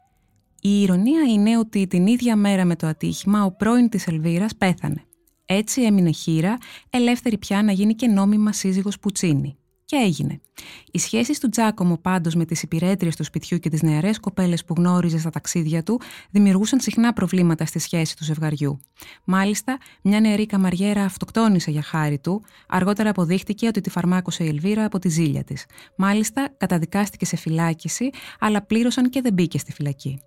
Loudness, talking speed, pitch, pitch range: -21 LUFS, 165 wpm, 190 Hz, 165-215 Hz